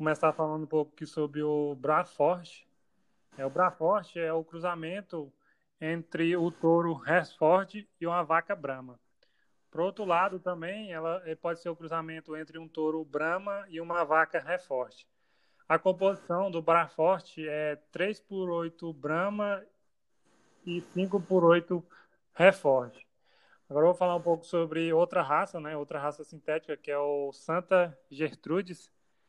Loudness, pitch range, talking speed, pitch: -30 LUFS, 155-180 Hz, 145 wpm, 165 Hz